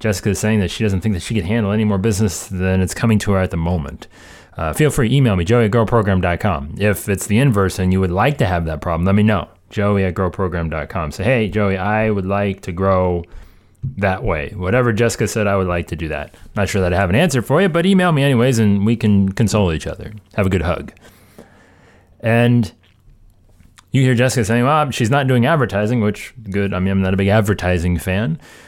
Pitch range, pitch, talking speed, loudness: 95-115 Hz, 100 Hz, 225 wpm, -17 LUFS